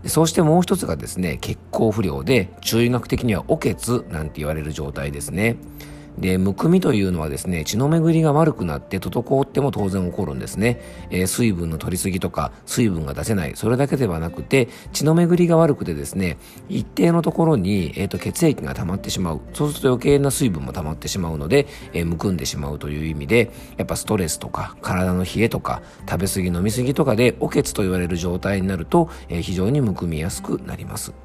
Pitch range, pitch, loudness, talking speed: 85-130 Hz, 95 Hz, -21 LUFS, 430 characters per minute